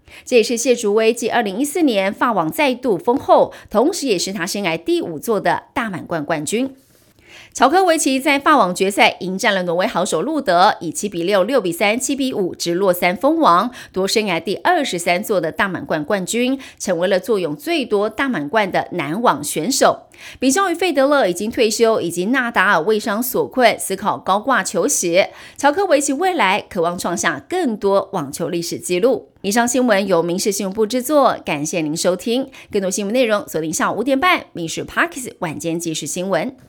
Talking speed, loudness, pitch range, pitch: 300 characters per minute, -18 LUFS, 180-270 Hz, 215 Hz